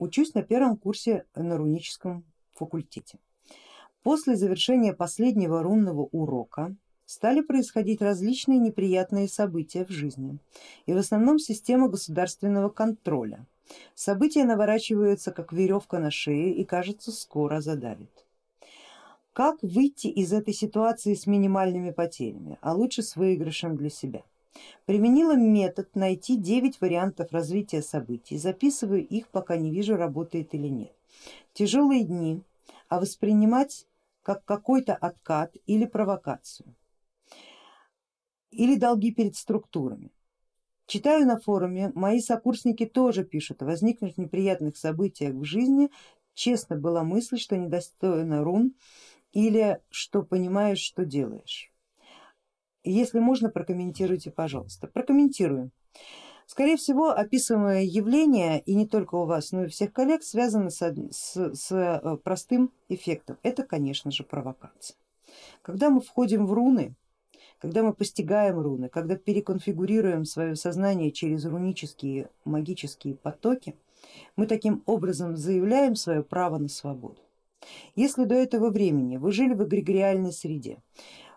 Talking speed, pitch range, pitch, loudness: 120 wpm, 170-230 Hz, 195 Hz, -26 LUFS